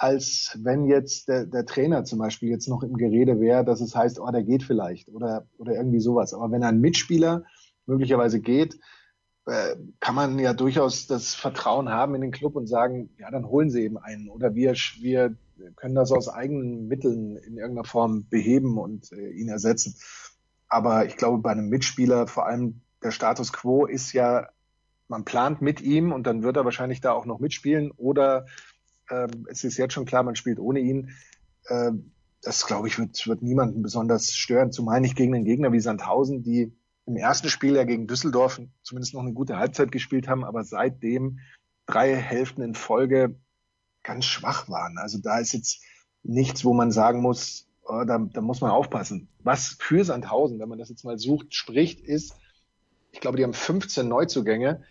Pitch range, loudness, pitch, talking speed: 115-135 Hz, -25 LUFS, 125 Hz, 185 wpm